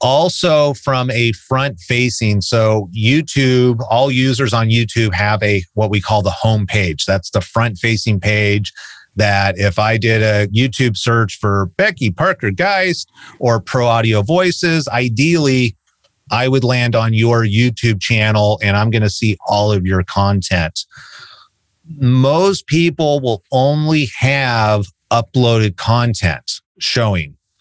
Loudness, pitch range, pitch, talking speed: -15 LUFS, 105-130 Hz, 115 Hz, 140 wpm